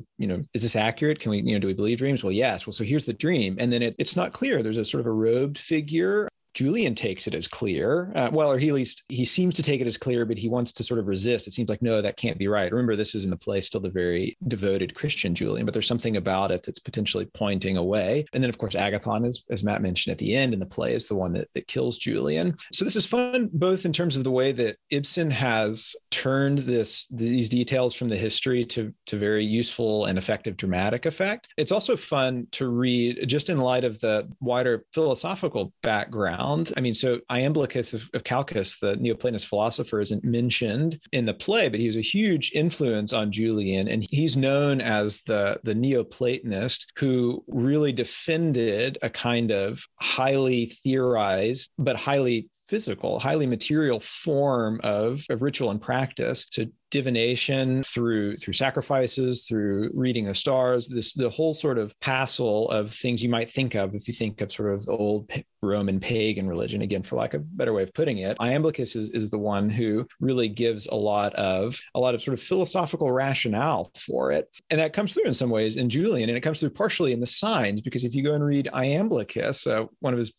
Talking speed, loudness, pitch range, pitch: 215 wpm, -25 LUFS, 110-140 Hz, 120 Hz